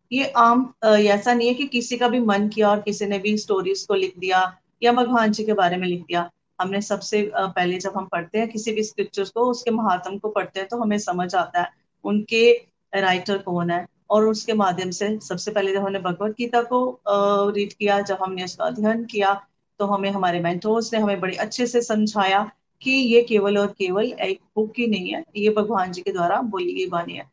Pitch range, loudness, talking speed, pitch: 190-230 Hz, -22 LUFS, 215 wpm, 205 Hz